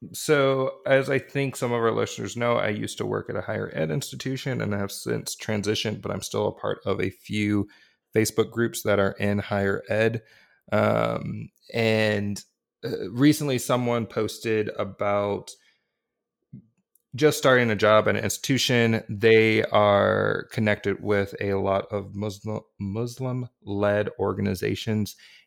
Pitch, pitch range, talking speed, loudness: 110 Hz, 100-120 Hz, 145 wpm, -25 LUFS